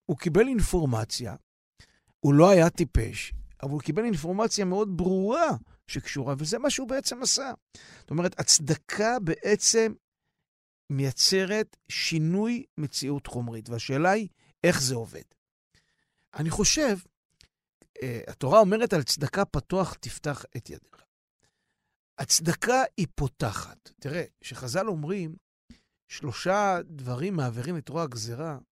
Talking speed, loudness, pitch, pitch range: 115 wpm, -26 LUFS, 170 Hz, 140-200 Hz